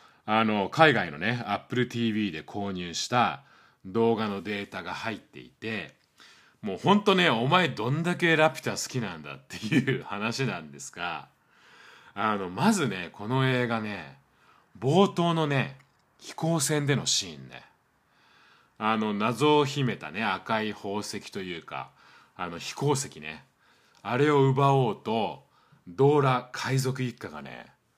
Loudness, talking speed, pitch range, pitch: -27 LUFS, 260 characters per minute, 105-145 Hz, 120 Hz